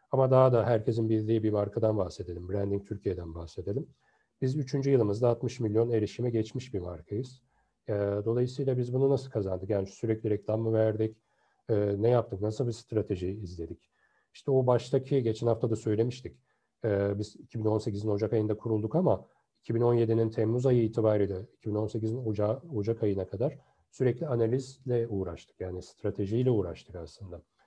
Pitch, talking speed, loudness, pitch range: 110 Hz, 140 wpm, -30 LUFS, 100-120 Hz